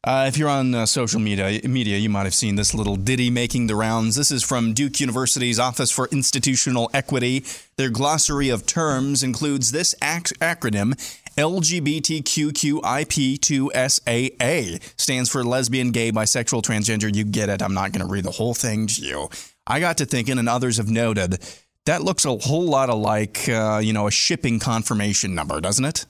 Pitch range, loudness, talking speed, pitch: 110-140 Hz, -21 LUFS, 180 wpm, 125 Hz